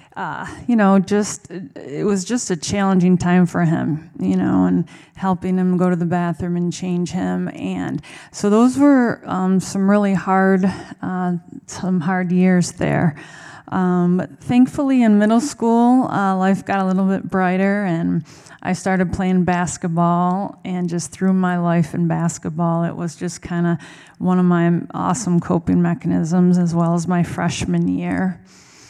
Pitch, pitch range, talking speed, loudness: 180 Hz, 170-190 Hz, 165 wpm, -18 LUFS